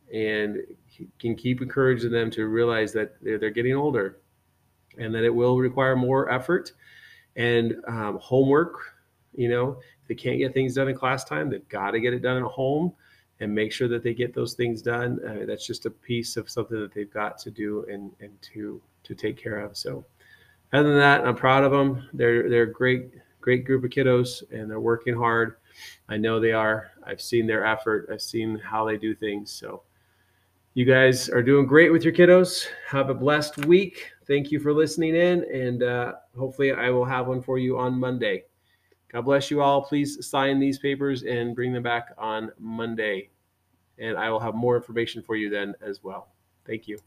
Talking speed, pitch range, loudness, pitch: 200 wpm, 110-135 Hz, -24 LUFS, 120 Hz